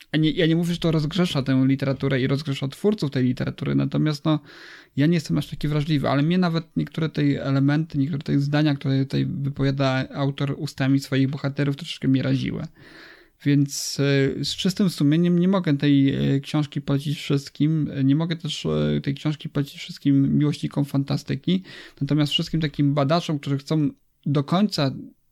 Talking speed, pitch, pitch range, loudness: 165 wpm, 145 Hz, 140-155 Hz, -23 LUFS